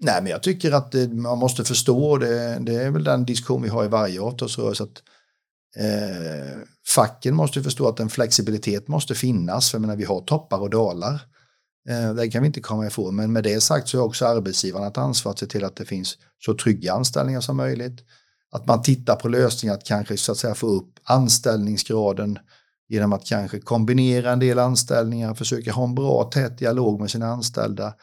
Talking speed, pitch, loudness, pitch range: 200 wpm, 115 Hz, -22 LUFS, 105-125 Hz